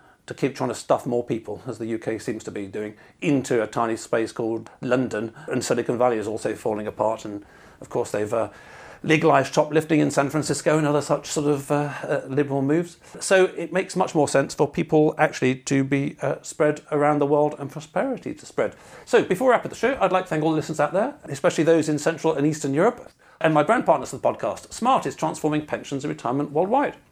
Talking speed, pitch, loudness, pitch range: 230 wpm, 145 Hz, -23 LUFS, 130-160 Hz